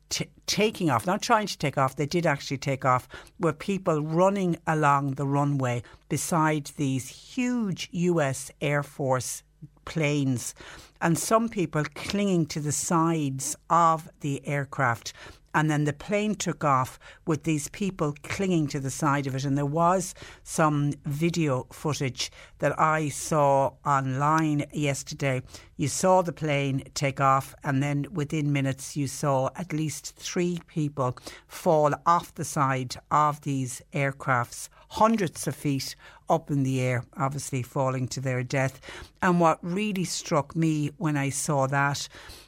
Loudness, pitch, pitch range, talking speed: -27 LUFS, 145 Hz, 135-165 Hz, 150 wpm